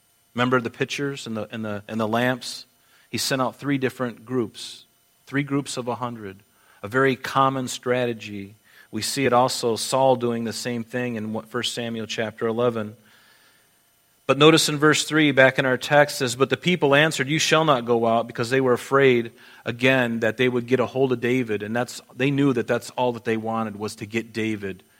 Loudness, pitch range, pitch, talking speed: -22 LUFS, 115-130 Hz, 125 Hz, 205 wpm